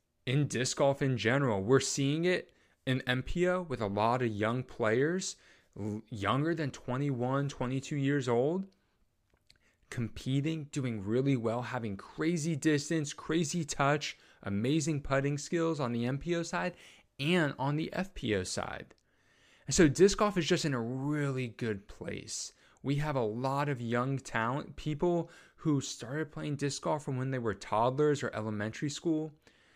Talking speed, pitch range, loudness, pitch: 150 wpm, 125-155 Hz, -32 LUFS, 140 Hz